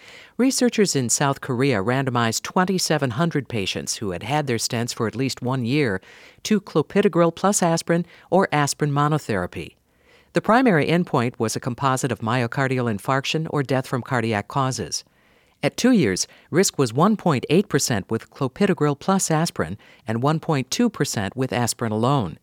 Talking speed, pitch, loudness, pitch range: 140 wpm, 140 Hz, -22 LUFS, 120-170 Hz